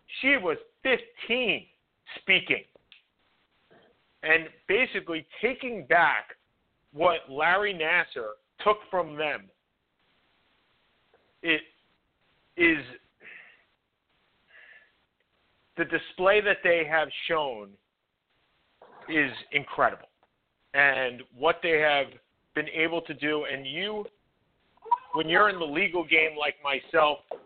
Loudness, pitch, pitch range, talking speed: -26 LUFS, 160 Hz, 145-195 Hz, 90 wpm